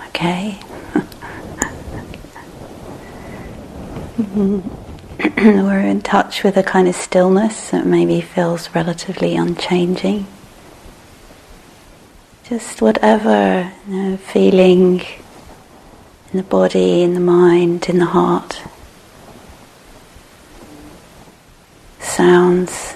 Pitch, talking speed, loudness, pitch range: 180 Hz, 75 wpm, -15 LUFS, 170-195 Hz